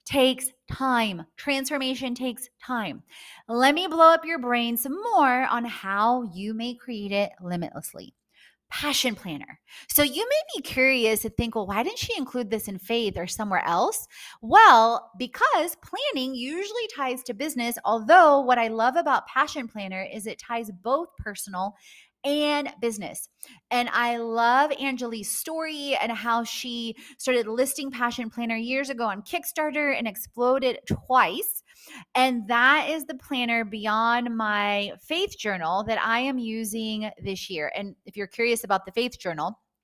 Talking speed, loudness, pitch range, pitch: 155 wpm, -24 LUFS, 225-275 Hz, 240 Hz